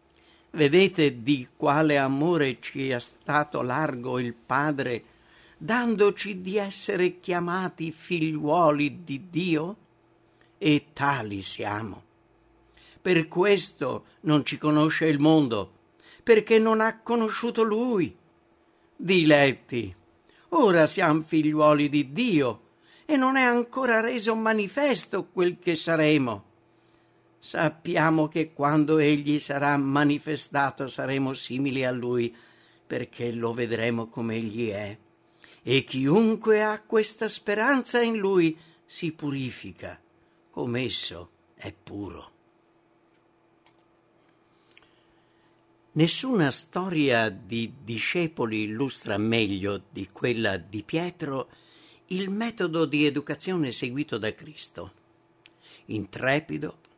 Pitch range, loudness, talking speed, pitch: 125-185 Hz, -25 LUFS, 100 wpm, 150 Hz